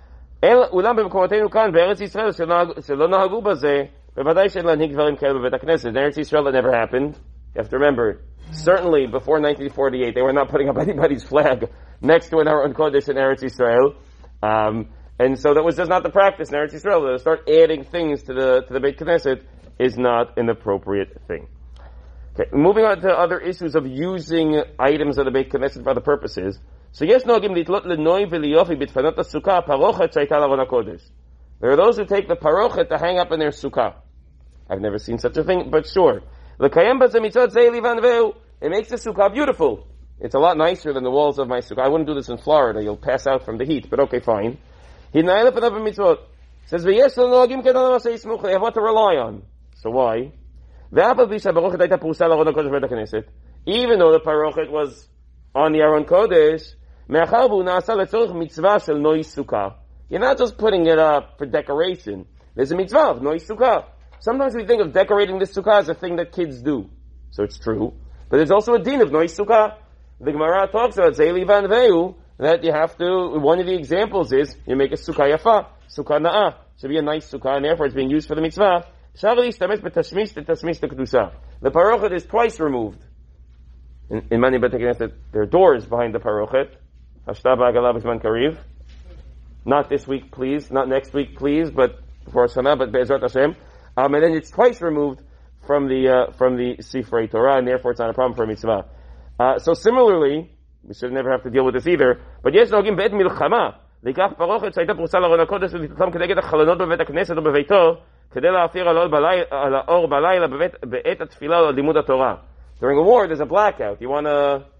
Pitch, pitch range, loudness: 150 Hz, 125-185 Hz, -19 LUFS